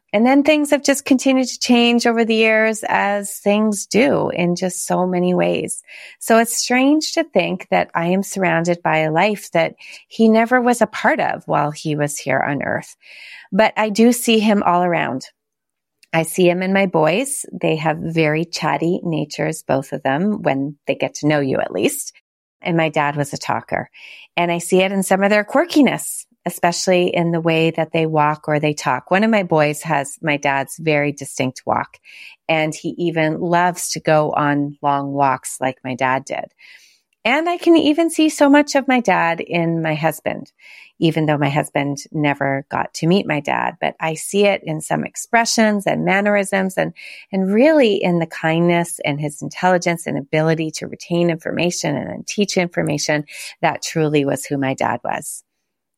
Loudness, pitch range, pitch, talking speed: -18 LUFS, 150-210 Hz, 175 Hz, 190 wpm